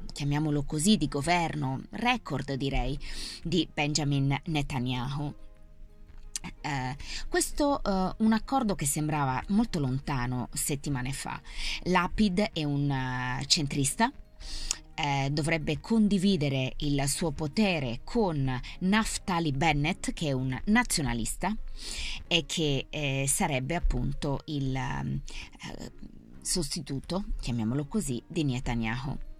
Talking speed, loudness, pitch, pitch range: 100 wpm, -29 LUFS, 145 Hz, 130-175 Hz